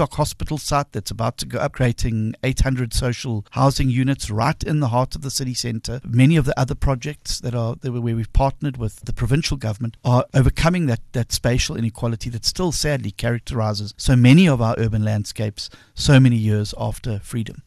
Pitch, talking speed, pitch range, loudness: 125 Hz, 185 wpm, 115-135 Hz, -20 LUFS